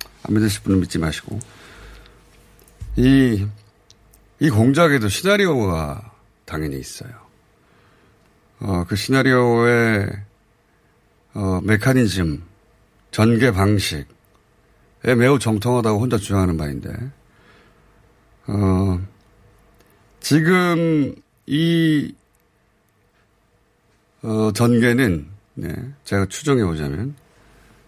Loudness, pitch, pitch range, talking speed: -19 LUFS, 110 Hz, 100-130 Hz, 170 characters per minute